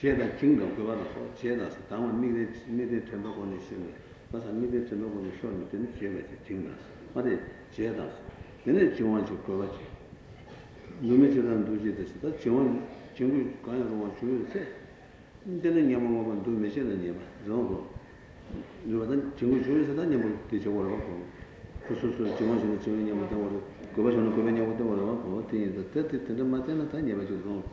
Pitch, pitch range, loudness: 115 Hz, 100-125 Hz, -30 LUFS